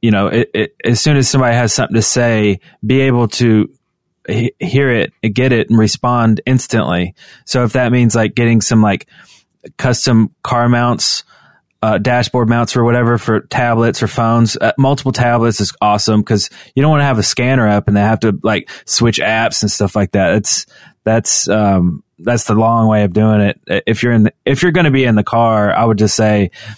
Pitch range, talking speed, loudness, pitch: 105-120 Hz, 210 wpm, -13 LUFS, 115 Hz